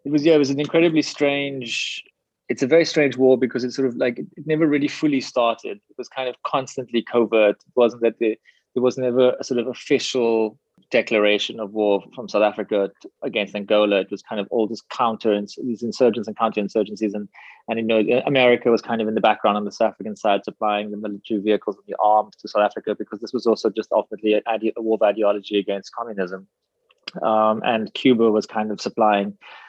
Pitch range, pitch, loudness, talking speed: 105-125 Hz, 110 Hz, -21 LUFS, 210 wpm